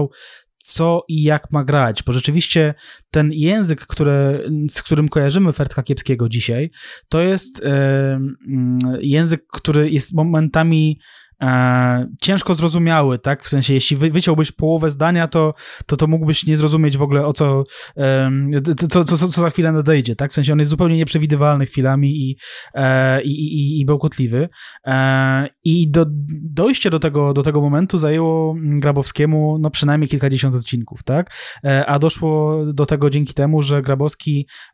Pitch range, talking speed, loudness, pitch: 140-160 Hz, 150 wpm, -16 LUFS, 150 Hz